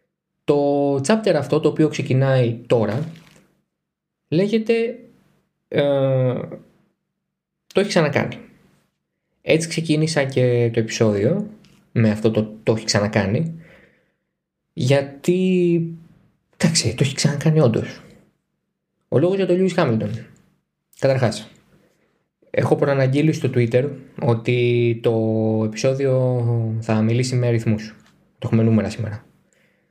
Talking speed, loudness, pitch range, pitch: 100 wpm, -20 LUFS, 115-170 Hz, 140 Hz